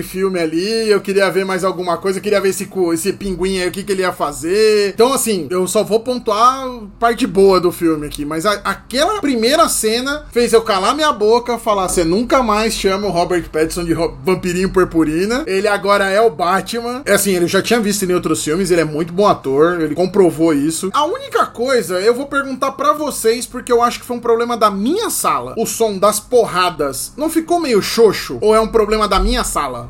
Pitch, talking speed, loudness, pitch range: 205 Hz, 220 wpm, -15 LUFS, 180-240 Hz